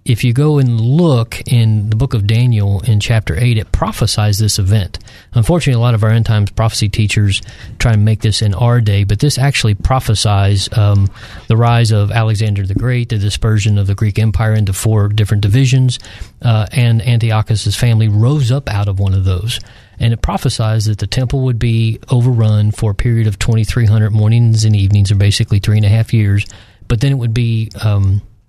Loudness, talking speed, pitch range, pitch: -13 LUFS, 200 wpm, 105-120 Hz, 110 Hz